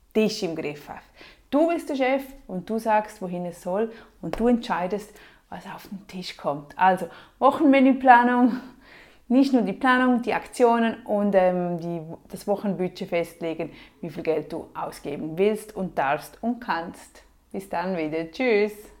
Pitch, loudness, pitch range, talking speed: 205 Hz, -24 LUFS, 175-245 Hz, 160 wpm